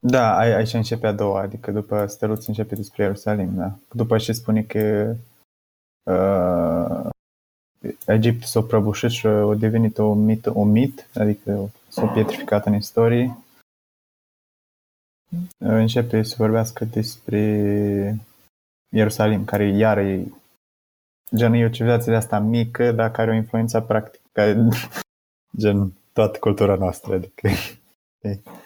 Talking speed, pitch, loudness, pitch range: 130 wpm, 105 Hz, -21 LUFS, 100-115 Hz